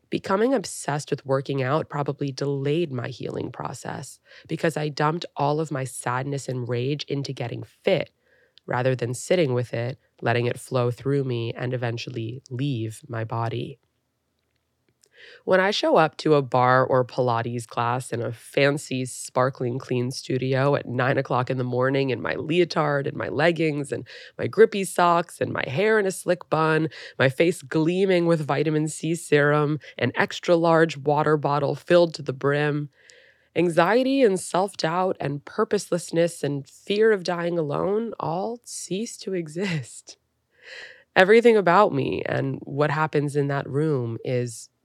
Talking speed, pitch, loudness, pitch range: 155 wpm, 145 Hz, -24 LUFS, 130-170 Hz